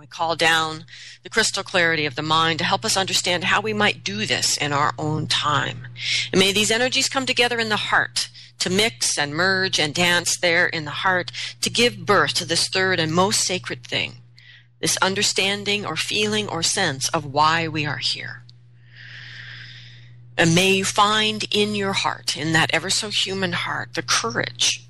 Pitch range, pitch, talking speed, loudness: 145-195 Hz, 170 Hz, 185 wpm, -20 LUFS